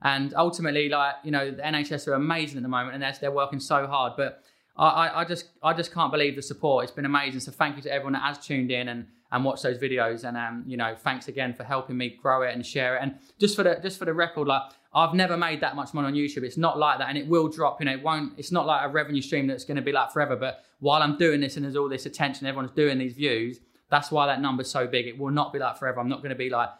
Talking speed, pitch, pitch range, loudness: 295 wpm, 140 Hz, 130-150 Hz, -26 LUFS